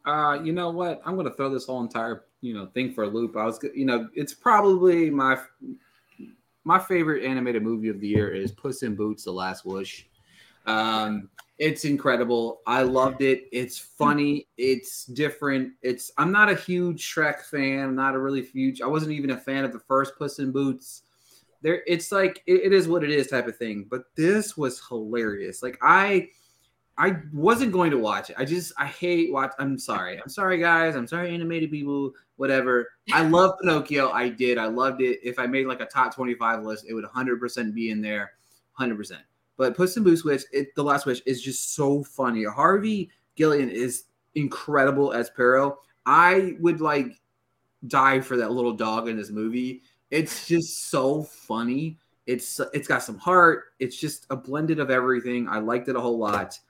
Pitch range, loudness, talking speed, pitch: 120-155 Hz, -24 LUFS, 195 wpm, 135 Hz